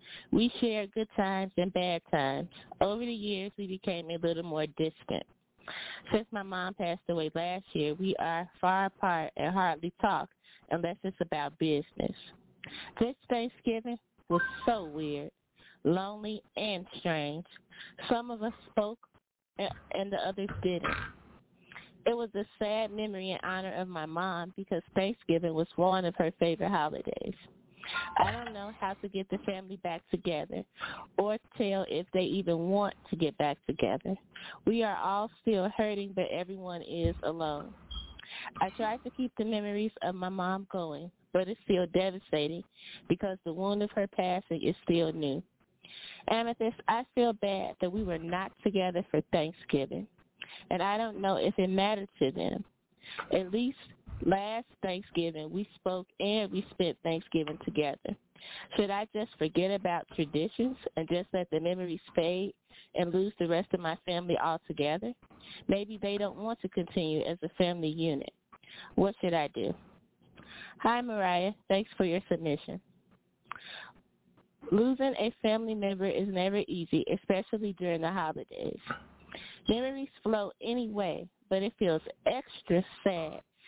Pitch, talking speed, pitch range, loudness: 190 Hz, 150 wpm, 170-210 Hz, -33 LUFS